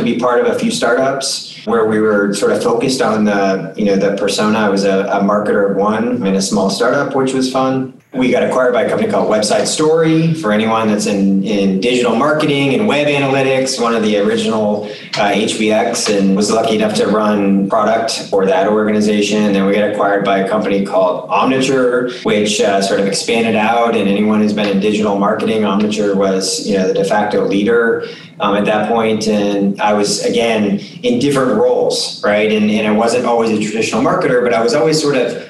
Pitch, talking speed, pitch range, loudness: 110 Hz, 215 wpm, 105-130 Hz, -14 LUFS